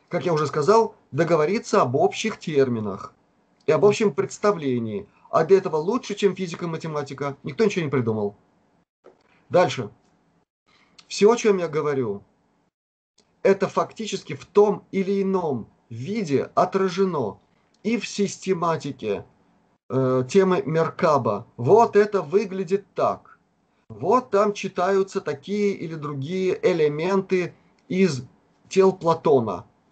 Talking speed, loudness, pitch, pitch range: 115 wpm, -23 LUFS, 190 Hz, 150-200 Hz